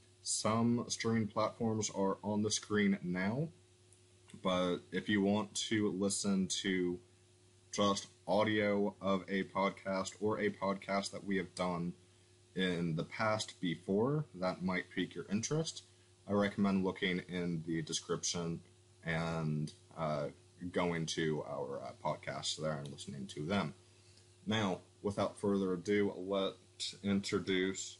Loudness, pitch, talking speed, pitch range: -37 LUFS, 95 Hz, 130 wpm, 90-100 Hz